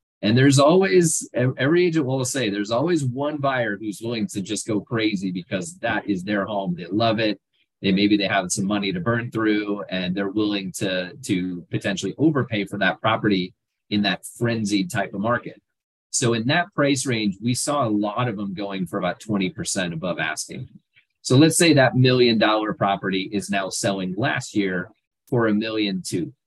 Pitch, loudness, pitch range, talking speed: 105 Hz, -22 LUFS, 100-125 Hz, 190 wpm